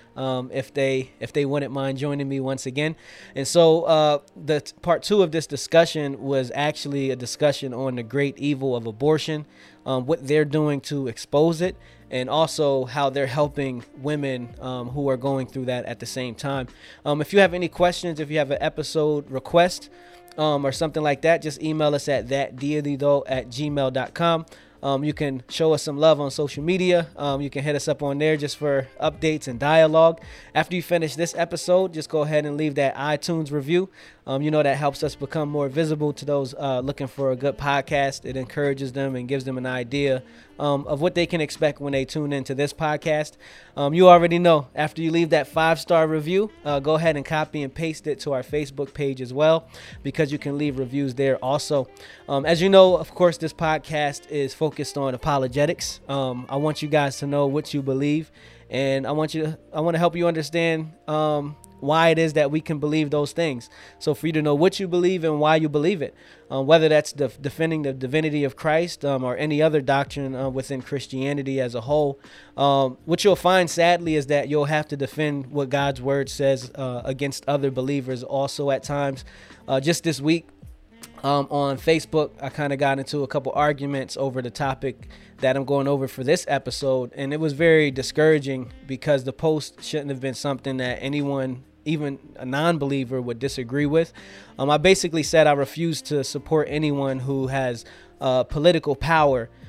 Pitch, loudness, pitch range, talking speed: 145 Hz, -23 LUFS, 135-155 Hz, 205 wpm